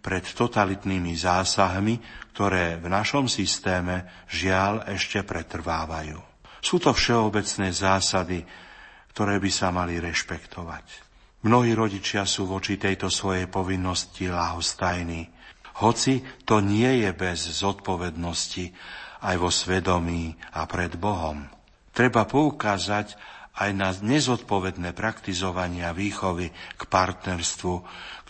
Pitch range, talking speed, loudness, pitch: 90-105 Hz, 105 wpm, -25 LUFS, 95 Hz